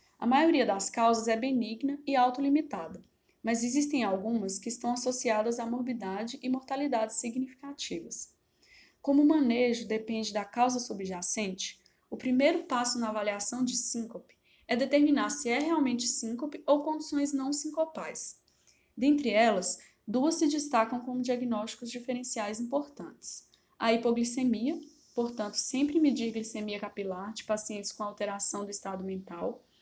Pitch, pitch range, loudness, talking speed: 240 Hz, 215-275 Hz, -30 LUFS, 135 wpm